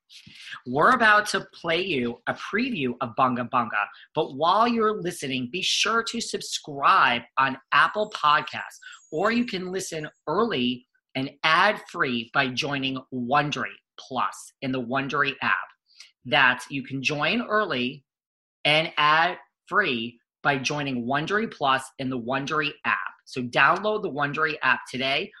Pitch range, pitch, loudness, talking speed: 130-195 Hz, 150 Hz, -24 LUFS, 140 wpm